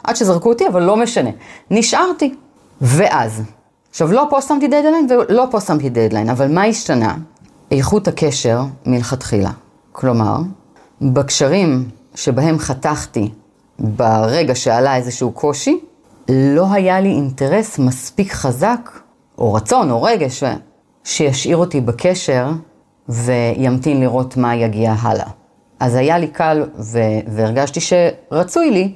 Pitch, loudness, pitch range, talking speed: 140 Hz, -15 LUFS, 125-190 Hz, 120 wpm